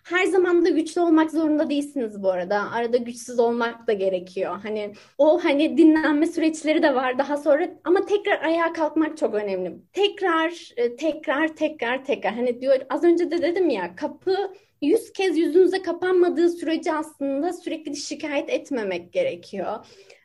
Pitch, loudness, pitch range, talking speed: 310 Hz, -23 LUFS, 260-340 Hz, 150 wpm